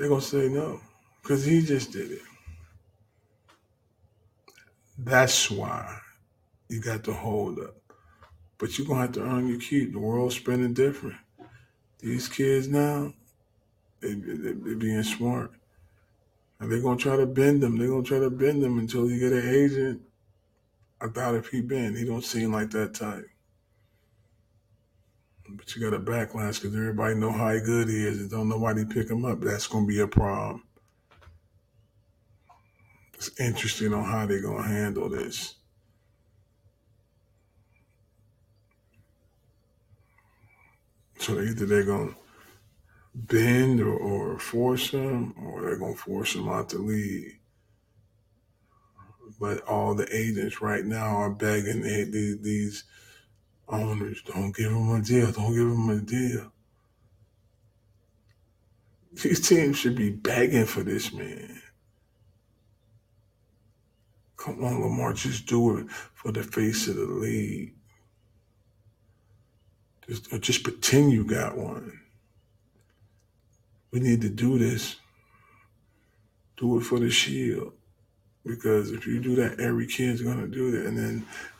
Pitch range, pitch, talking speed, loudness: 105-120 Hz, 110 Hz, 140 wpm, -27 LUFS